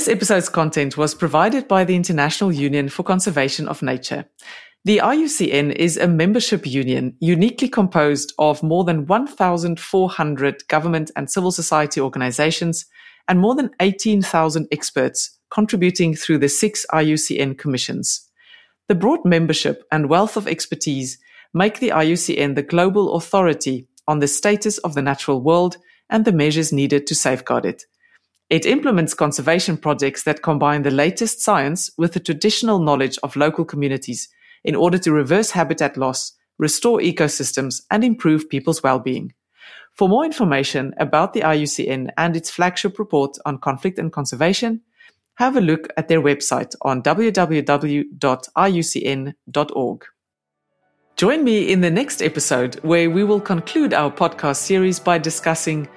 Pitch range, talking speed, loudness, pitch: 145-190 Hz, 145 wpm, -18 LUFS, 165 Hz